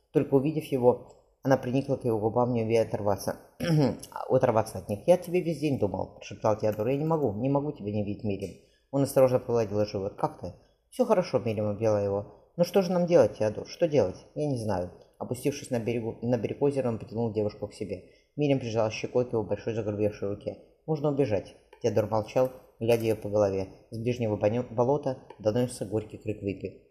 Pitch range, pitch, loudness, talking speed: 105-135 Hz, 115 Hz, -28 LUFS, 190 wpm